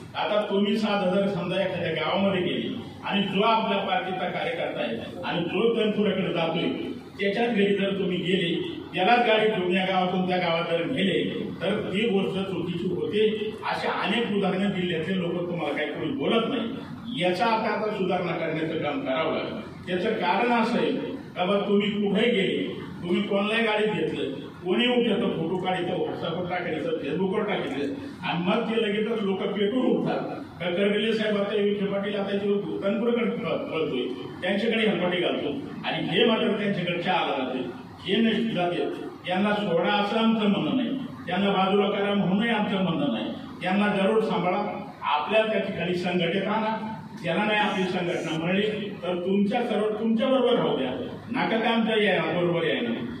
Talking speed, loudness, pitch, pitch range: 160 wpm, -26 LUFS, 200 Hz, 180-220 Hz